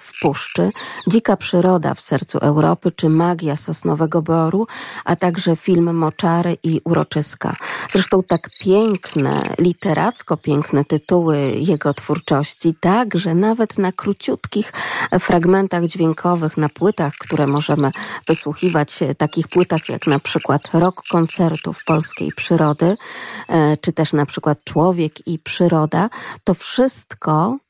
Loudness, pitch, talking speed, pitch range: -18 LUFS, 170 Hz, 120 wpm, 155-185 Hz